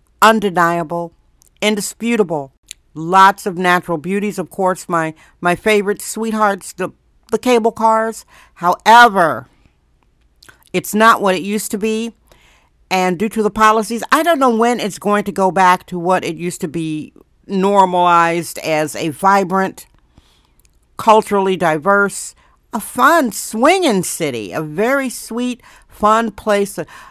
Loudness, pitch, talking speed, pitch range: -15 LUFS, 200 Hz, 135 wpm, 175-220 Hz